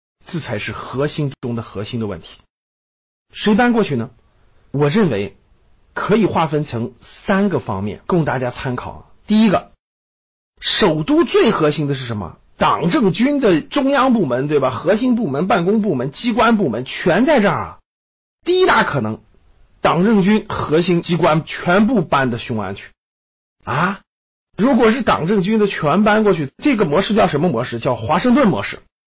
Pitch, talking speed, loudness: 155 Hz, 245 characters per minute, -17 LUFS